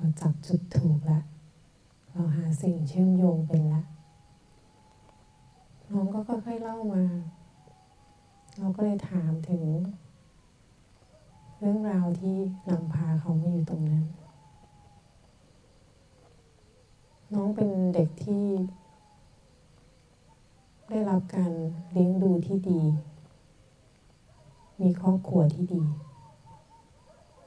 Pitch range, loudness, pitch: 150-185 Hz, -28 LUFS, 165 Hz